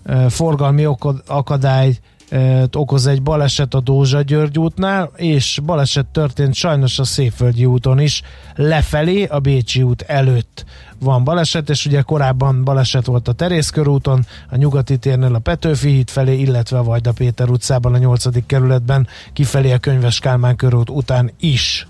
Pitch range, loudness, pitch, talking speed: 125-145 Hz, -15 LUFS, 135 Hz, 155 wpm